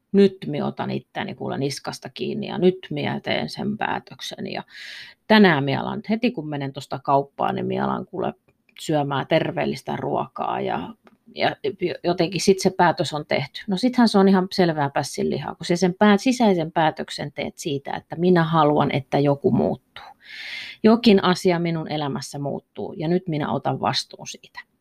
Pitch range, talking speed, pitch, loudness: 150-200 Hz, 160 wpm, 180 Hz, -22 LUFS